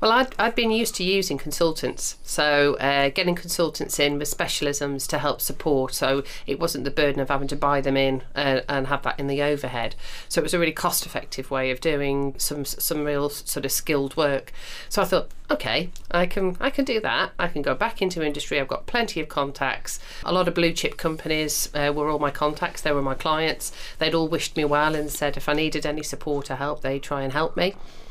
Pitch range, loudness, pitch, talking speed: 140-165 Hz, -24 LUFS, 145 Hz, 230 wpm